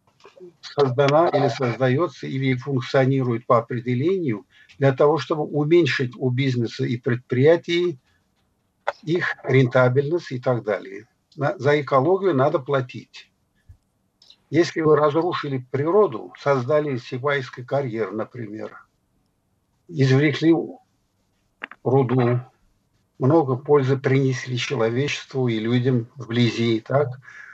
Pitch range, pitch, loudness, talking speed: 120-145 Hz, 130 Hz, -21 LUFS, 95 wpm